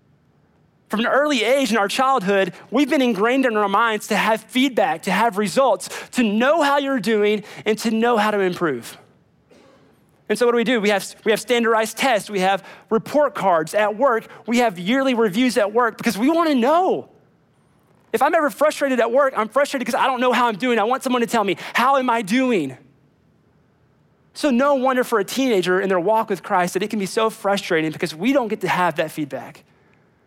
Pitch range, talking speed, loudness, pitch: 195-260 Hz, 215 wpm, -19 LUFS, 225 Hz